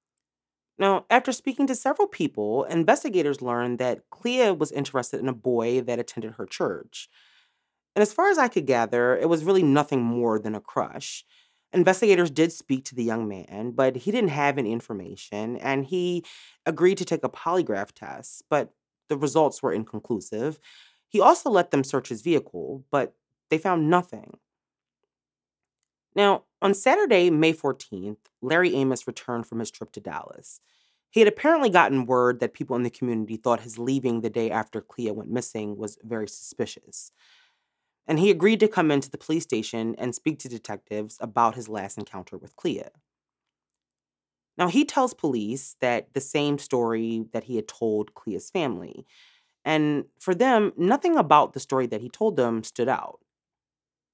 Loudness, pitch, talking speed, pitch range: -24 LUFS, 135 Hz, 170 wpm, 115-180 Hz